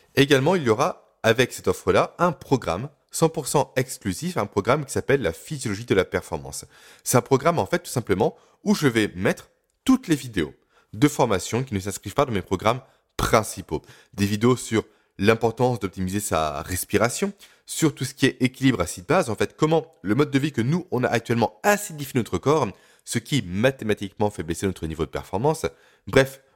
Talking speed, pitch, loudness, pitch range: 190 wpm, 120 Hz, -24 LUFS, 100-150 Hz